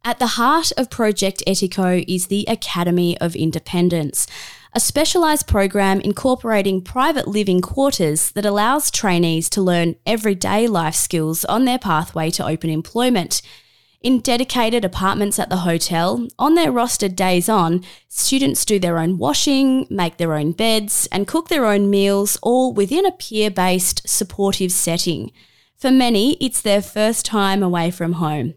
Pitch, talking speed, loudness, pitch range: 200 Hz, 150 wpm, -18 LUFS, 175-240 Hz